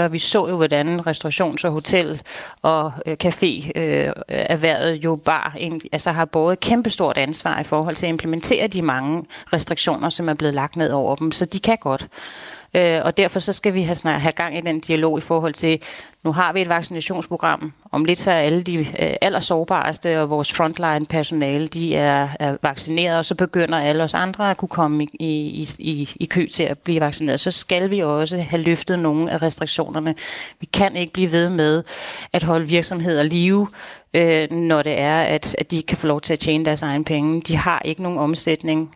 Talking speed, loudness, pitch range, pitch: 200 wpm, -20 LUFS, 155-175 Hz, 165 Hz